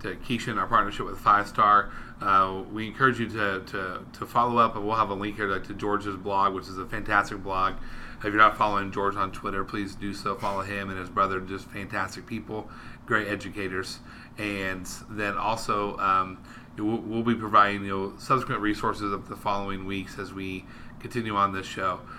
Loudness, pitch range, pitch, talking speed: -27 LUFS, 95-105 Hz, 100 Hz, 195 wpm